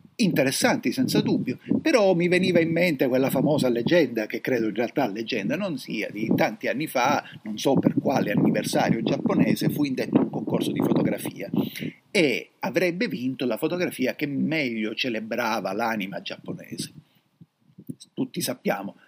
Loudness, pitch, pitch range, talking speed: -24 LUFS, 135 Hz, 120-175 Hz, 145 wpm